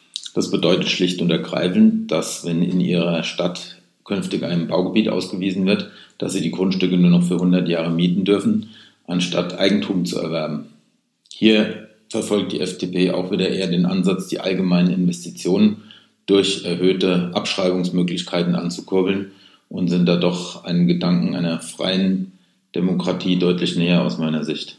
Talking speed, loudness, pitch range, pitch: 145 wpm, -20 LUFS, 90-100 Hz, 90 Hz